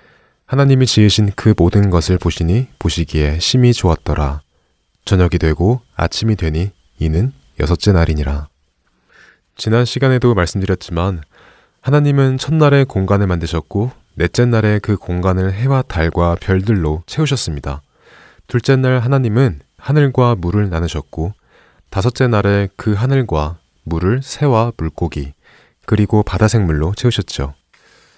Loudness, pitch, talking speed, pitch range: -15 LUFS, 95 Hz, 285 characters per minute, 85-120 Hz